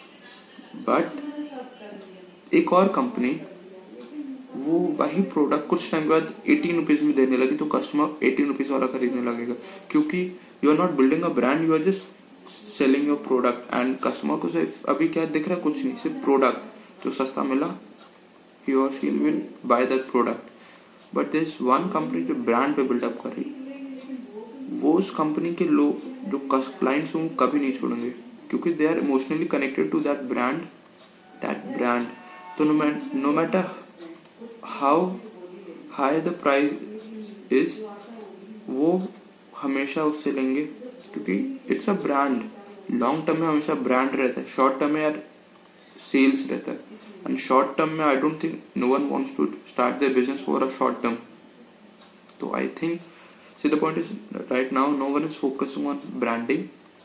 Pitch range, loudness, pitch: 140-220 Hz, -24 LUFS, 165 Hz